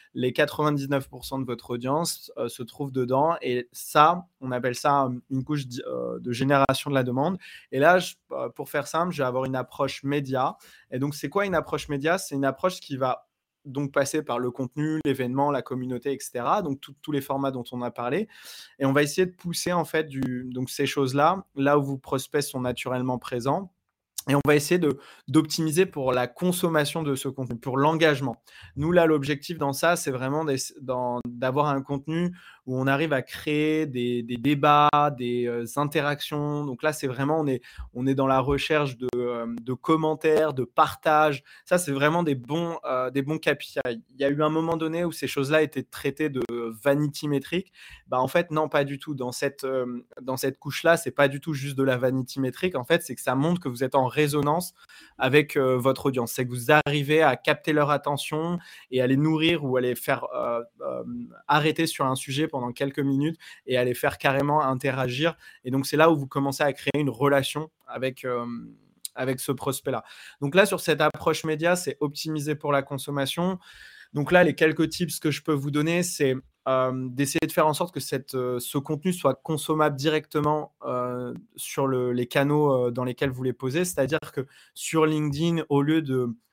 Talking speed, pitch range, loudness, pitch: 205 wpm, 130-155 Hz, -25 LUFS, 140 Hz